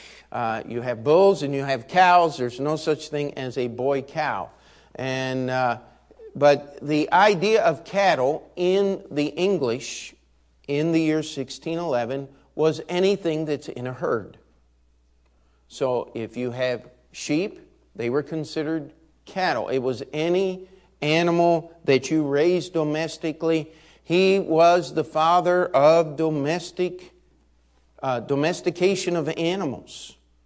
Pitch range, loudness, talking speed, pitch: 130-170 Hz, -23 LUFS, 130 wpm, 155 Hz